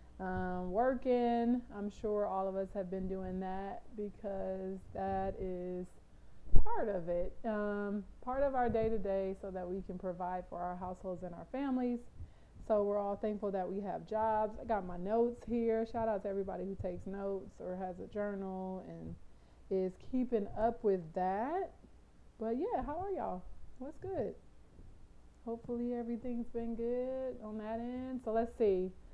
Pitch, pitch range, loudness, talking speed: 205 Hz, 185-230 Hz, -38 LUFS, 170 wpm